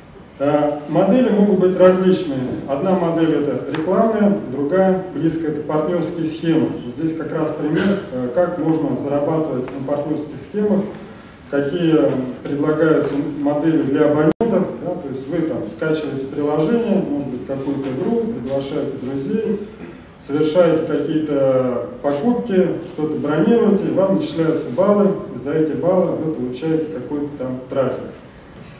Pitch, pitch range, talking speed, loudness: 155 Hz, 145-185 Hz, 125 wpm, -19 LUFS